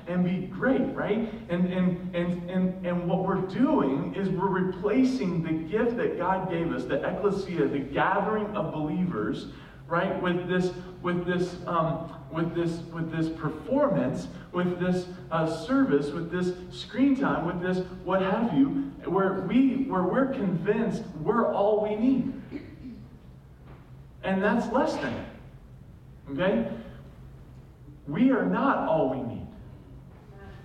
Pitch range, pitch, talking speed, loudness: 175-210 Hz, 185 Hz, 140 wpm, -27 LUFS